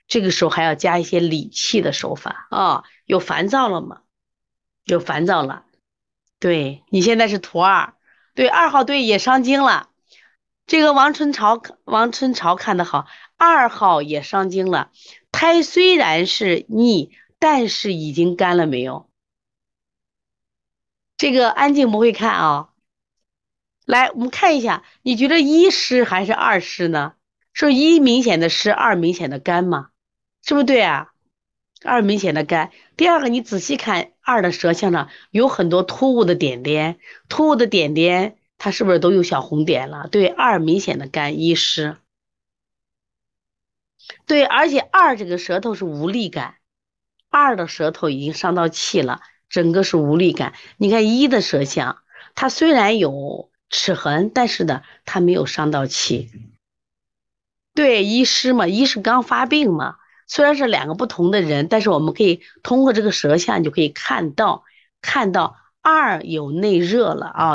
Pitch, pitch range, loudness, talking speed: 195 Hz, 165-255 Hz, -17 LUFS, 225 characters per minute